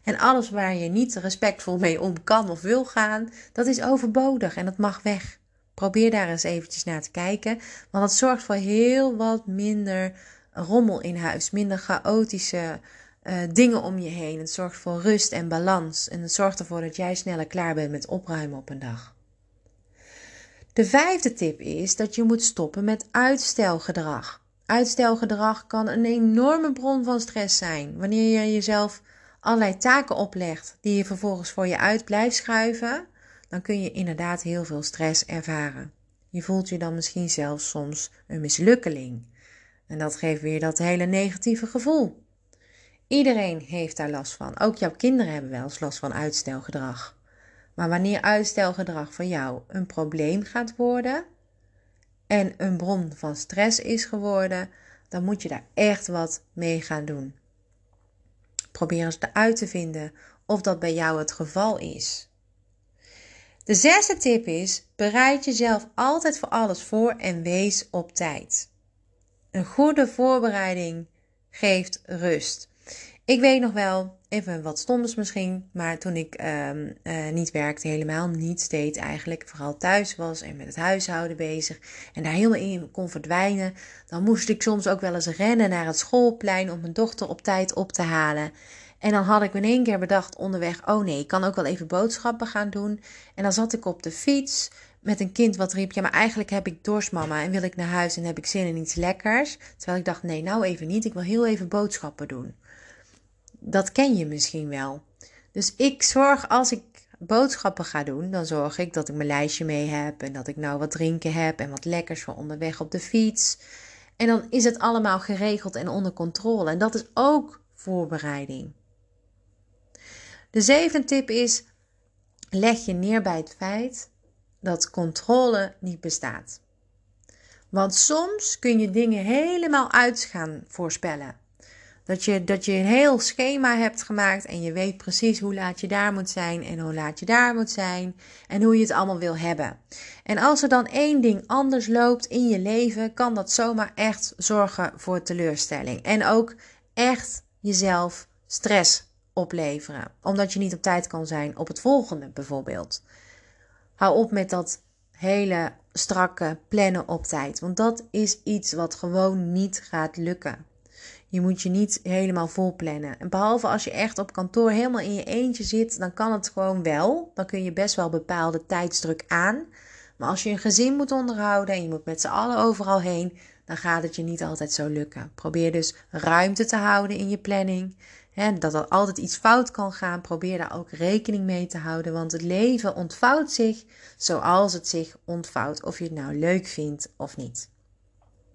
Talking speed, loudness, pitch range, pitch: 180 wpm, -24 LUFS, 160-215 Hz, 185 Hz